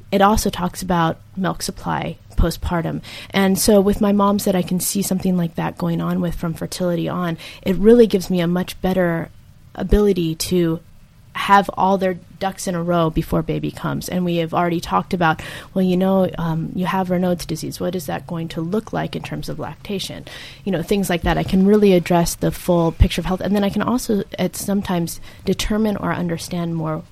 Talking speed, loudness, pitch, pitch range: 210 wpm, -20 LUFS, 180 Hz, 170-195 Hz